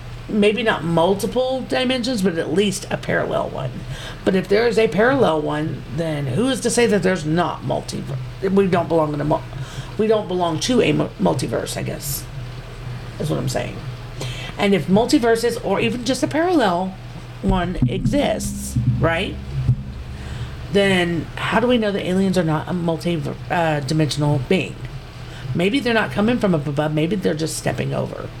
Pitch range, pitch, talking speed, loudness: 130-205 Hz, 165 Hz, 165 wpm, -20 LUFS